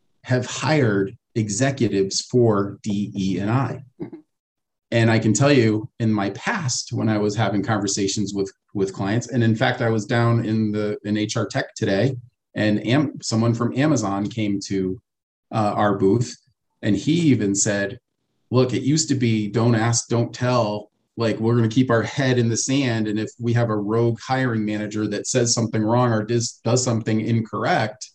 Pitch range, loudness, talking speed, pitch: 105-125 Hz, -21 LUFS, 185 wpm, 115 Hz